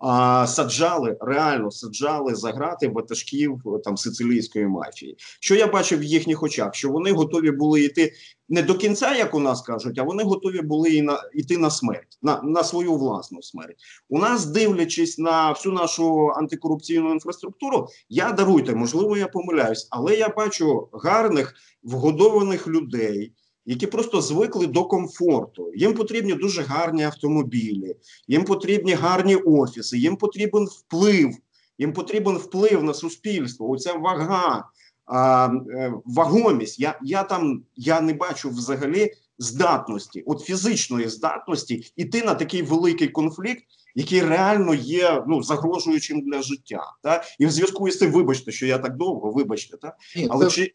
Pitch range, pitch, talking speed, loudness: 135-185 Hz, 160 Hz, 145 wpm, -22 LUFS